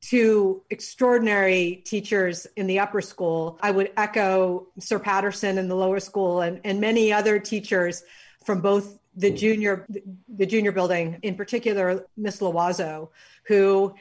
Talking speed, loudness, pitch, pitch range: 140 wpm, -23 LUFS, 195 Hz, 185-210 Hz